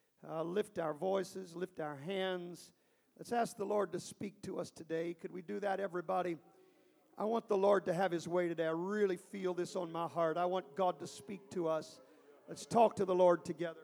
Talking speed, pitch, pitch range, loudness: 215 wpm, 180 Hz, 170-200 Hz, -37 LUFS